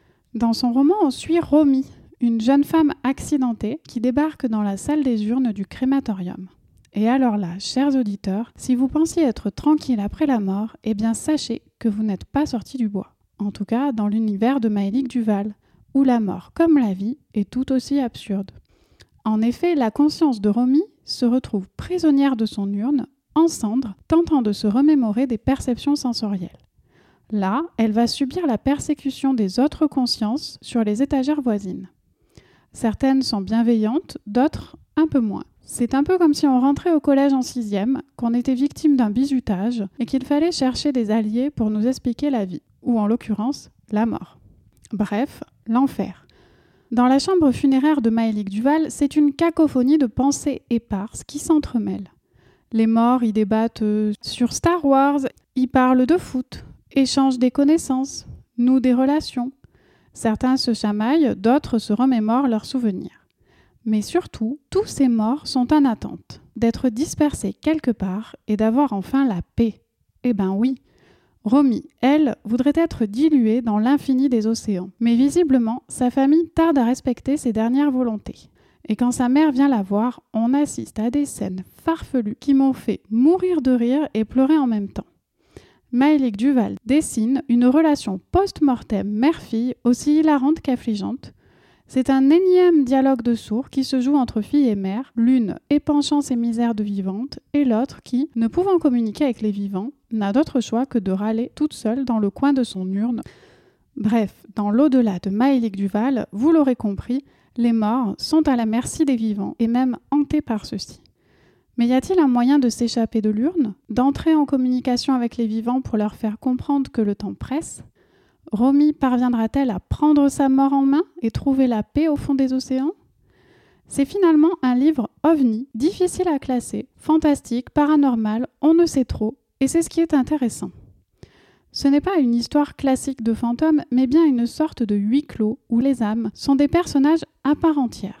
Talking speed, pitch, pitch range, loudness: 170 wpm, 255 Hz, 225-285 Hz, -20 LUFS